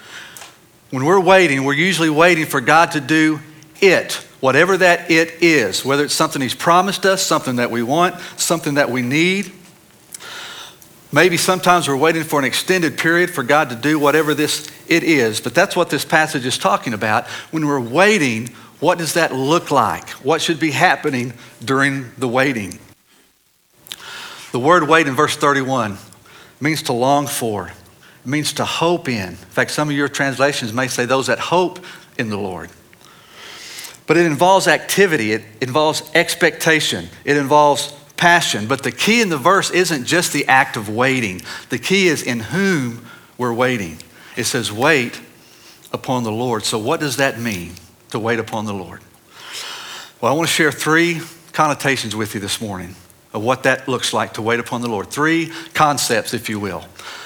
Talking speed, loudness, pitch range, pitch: 175 wpm, -16 LUFS, 120-165 Hz, 145 Hz